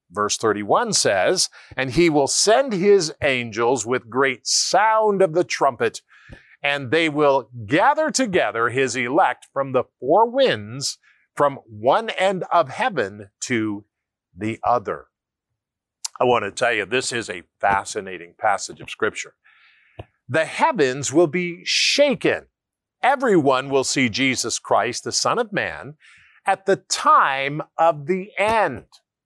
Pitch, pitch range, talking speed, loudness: 140 Hz, 125-180 Hz, 135 wpm, -20 LUFS